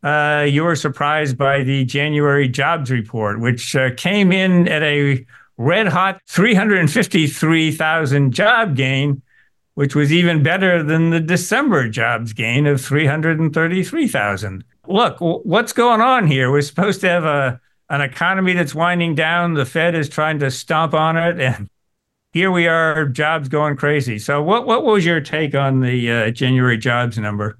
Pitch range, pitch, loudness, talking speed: 135-170 Hz, 150 Hz, -16 LUFS, 160 wpm